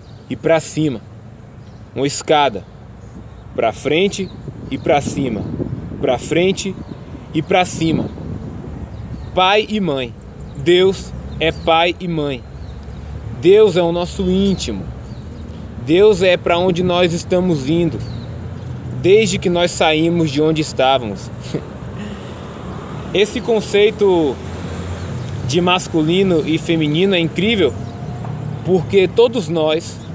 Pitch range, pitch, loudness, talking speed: 120-180 Hz, 160 Hz, -16 LUFS, 105 wpm